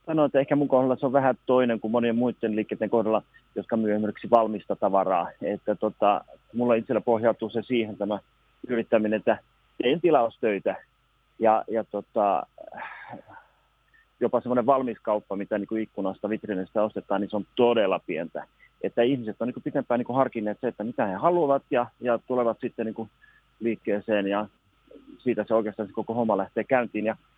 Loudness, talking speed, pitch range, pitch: -26 LUFS, 175 wpm, 105-120 Hz, 115 Hz